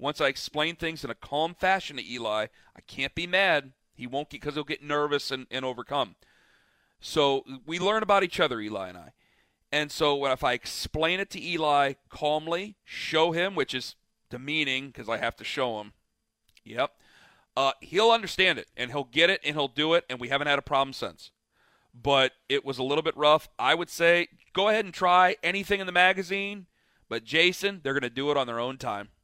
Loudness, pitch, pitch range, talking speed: -27 LUFS, 145 Hz, 130-170 Hz, 205 wpm